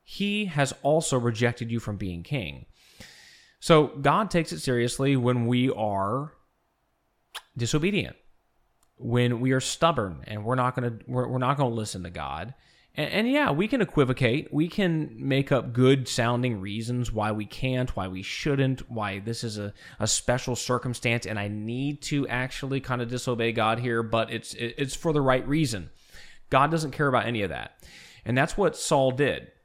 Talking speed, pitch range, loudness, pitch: 180 wpm, 115-140 Hz, -26 LUFS, 125 Hz